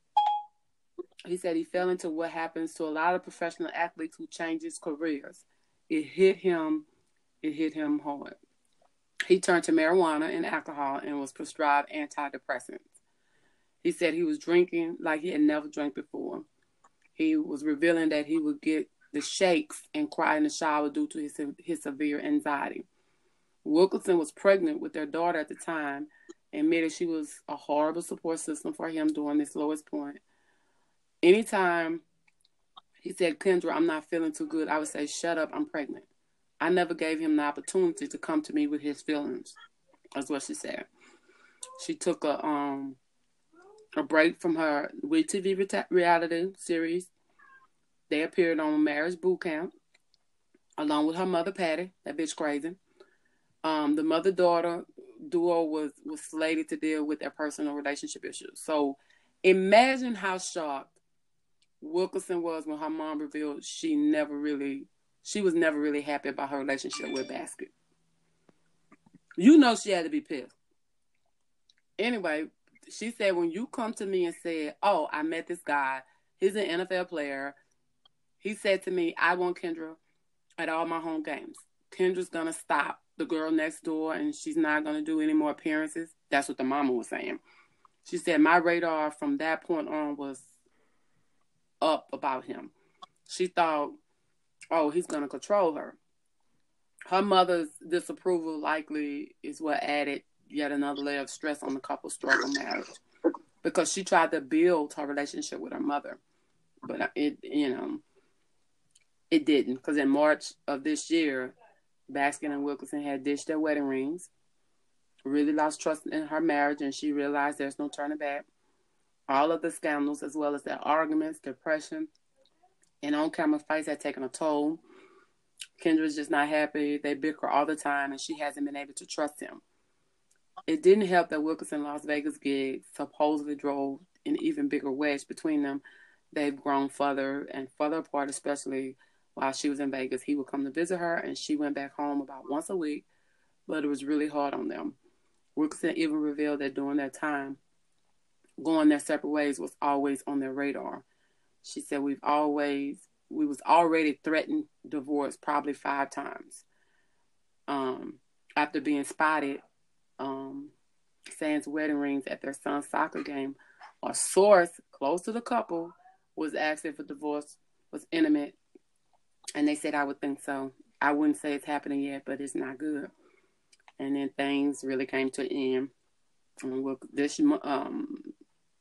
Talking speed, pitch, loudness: 165 wpm, 160 Hz, -30 LUFS